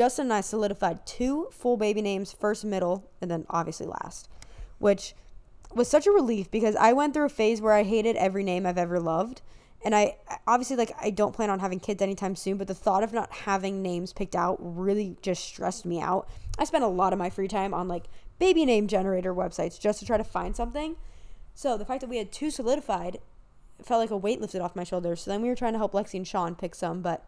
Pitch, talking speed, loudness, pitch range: 205 Hz, 240 wpm, -28 LUFS, 185-230 Hz